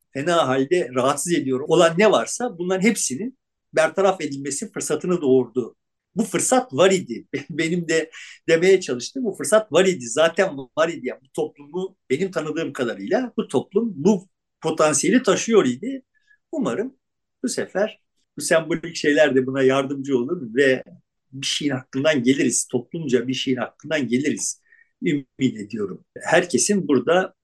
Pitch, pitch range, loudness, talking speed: 165 Hz, 135-195 Hz, -21 LUFS, 140 wpm